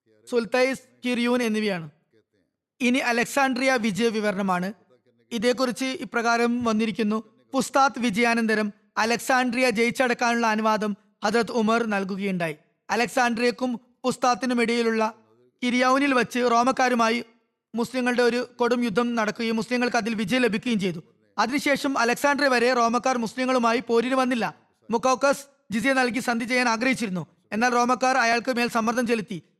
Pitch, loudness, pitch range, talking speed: 235 Hz, -23 LUFS, 220-255 Hz, 105 wpm